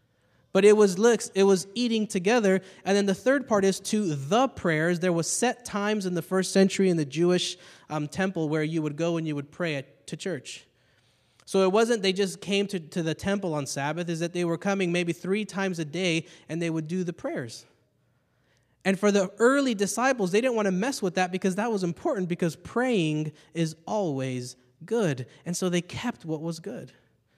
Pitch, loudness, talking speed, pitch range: 185 Hz, -26 LUFS, 210 wpm, 160-200 Hz